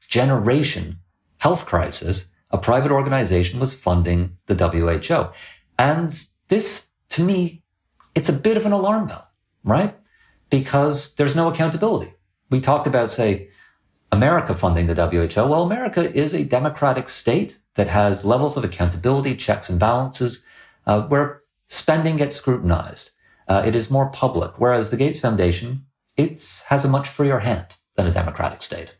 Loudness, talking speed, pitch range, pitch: -20 LUFS, 150 wpm, 95-145 Hz, 125 Hz